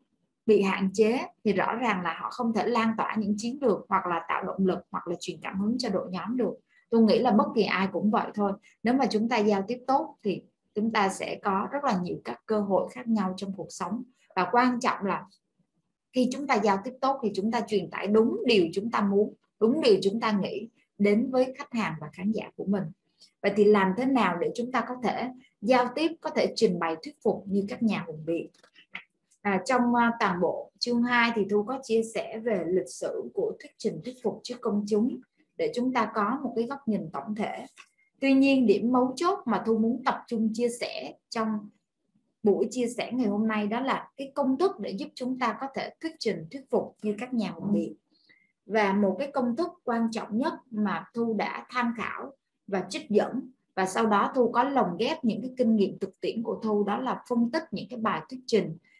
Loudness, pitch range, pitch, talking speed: -28 LUFS, 200-250 Hz, 225 Hz, 235 wpm